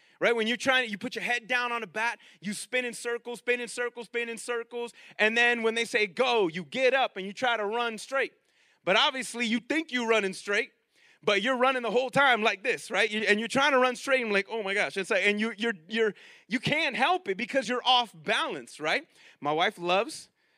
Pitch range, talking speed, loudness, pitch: 215-255 Hz, 250 wpm, -27 LUFS, 235 Hz